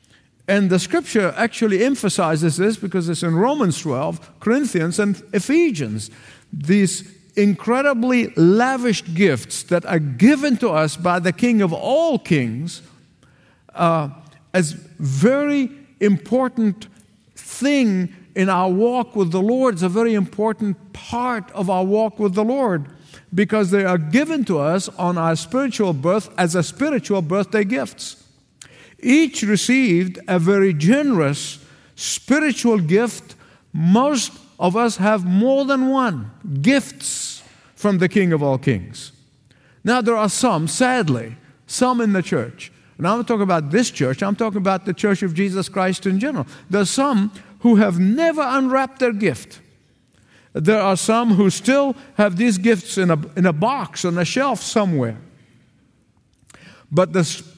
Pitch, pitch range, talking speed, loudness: 195 Hz, 165-230 Hz, 145 wpm, -19 LUFS